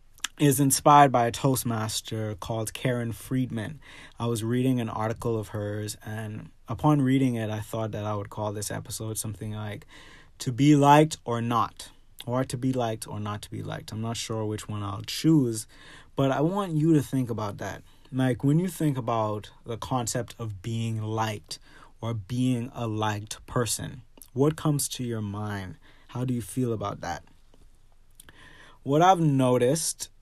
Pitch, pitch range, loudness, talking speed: 115 Hz, 110-135 Hz, -27 LUFS, 175 wpm